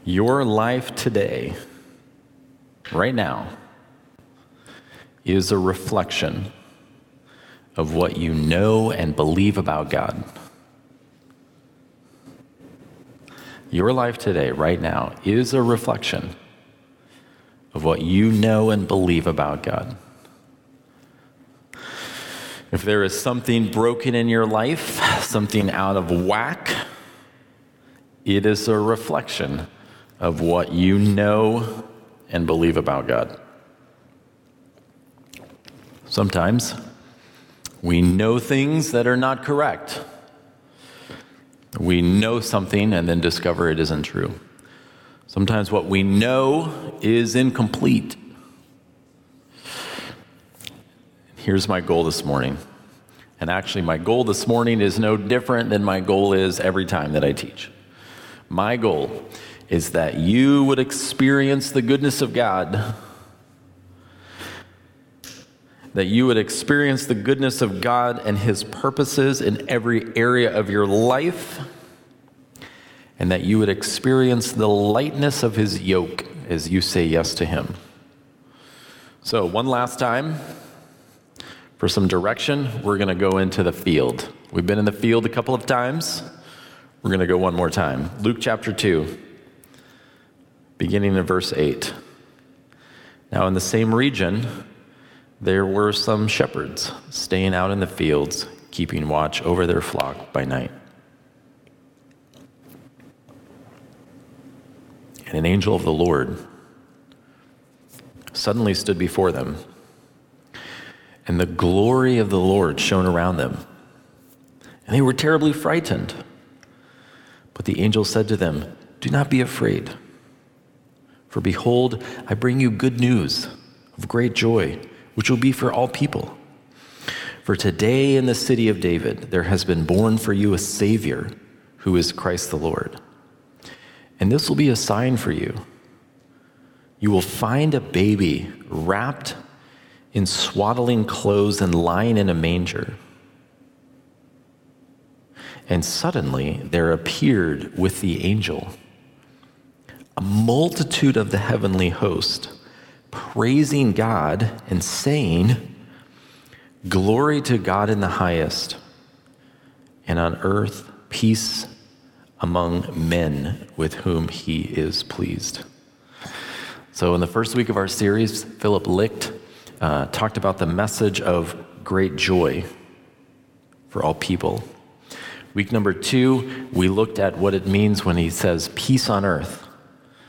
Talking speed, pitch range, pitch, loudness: 120 wpm, 95-130 Hz, 105 Hz, -21 LUFS